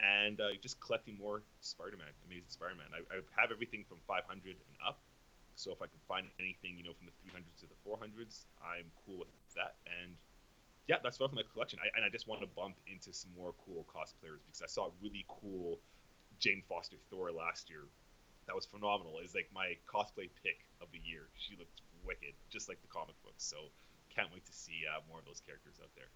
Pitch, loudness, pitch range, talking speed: 90 Hz, -43 LUFS, 85-105 Hz, 220 wpm